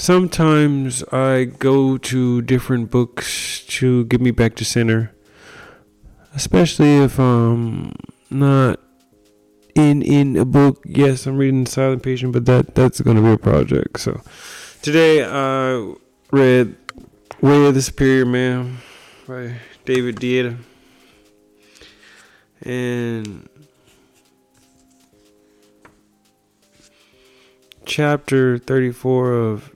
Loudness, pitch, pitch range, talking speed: -17 LUFS, 125 Hz, 110-135 Hz, 100 wpm